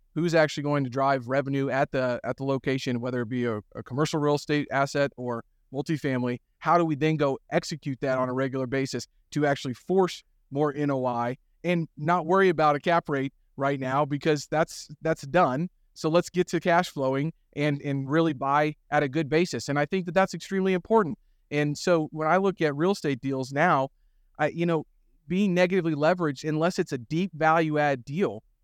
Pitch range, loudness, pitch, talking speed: 135-165 Hz, -26 LUFS, 150 Hz, 200 wpm